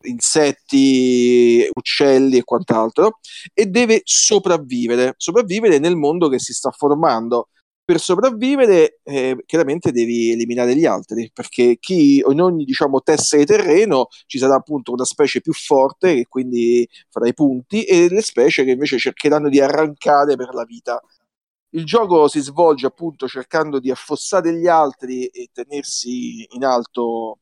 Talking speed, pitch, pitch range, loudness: 145 wpm, 145 Hz, 125-180 Hz, -16 LUFS